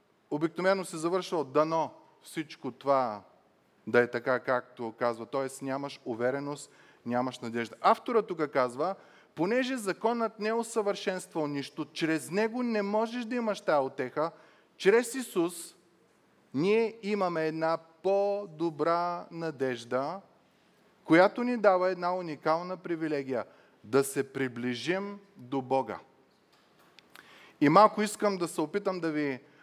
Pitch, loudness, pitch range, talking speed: 165 Hz, -30 LUFS, 135-200 Hz, 120 wpm